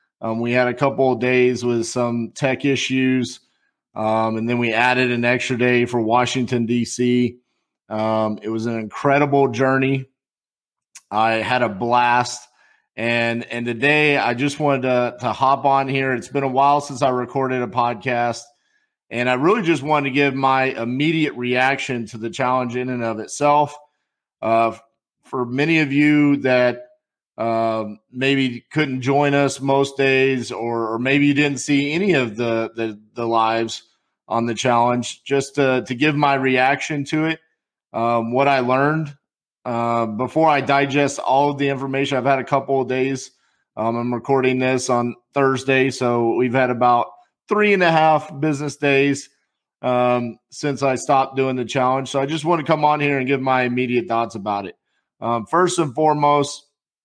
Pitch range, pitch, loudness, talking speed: 120-140 Hz, 130 Hz, -19 LUFS, 175 wpm